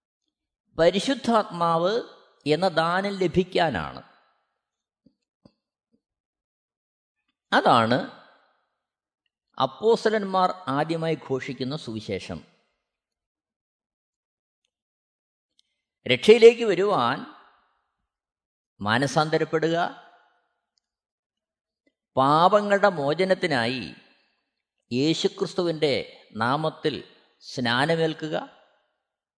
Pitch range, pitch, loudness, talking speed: 145-190 Hz, 165 Hz, -23 LUFS, 35 wpm